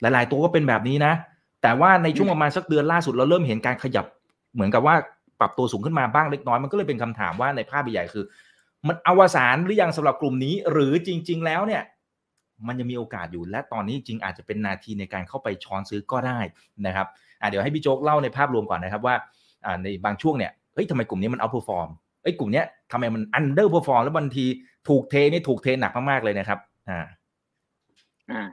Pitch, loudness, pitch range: 130 Hz, -23 LUFS, 105-150 Hz